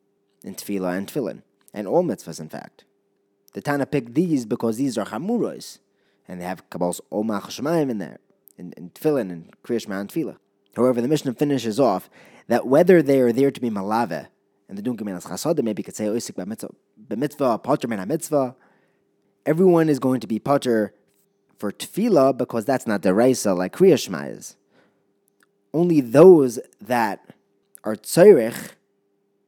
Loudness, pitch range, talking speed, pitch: -21 LUFS, 100-140 Hz, 165 wpm, 110 Hz